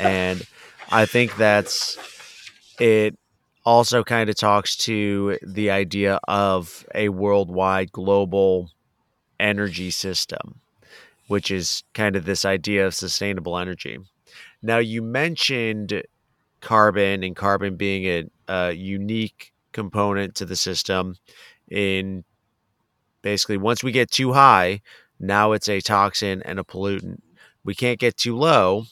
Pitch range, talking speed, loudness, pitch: 95-110 Hz, 125 wpm, -21 LUFS, 100 Hz